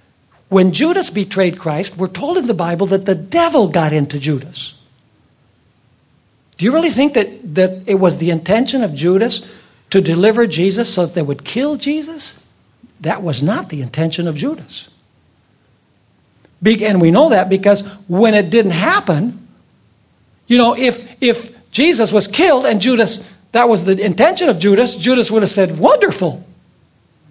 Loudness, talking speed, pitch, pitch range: -14 LUFS, 160 wpm, 200 Hz, 170-235 Hz